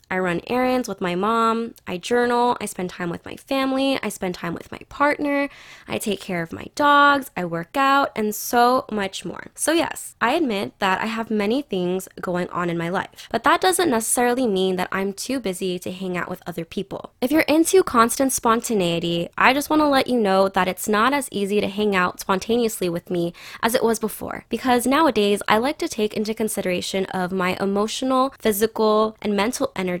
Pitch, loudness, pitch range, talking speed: 215 Hz, -21 LUFS, 185-255 Hz, 210 wpm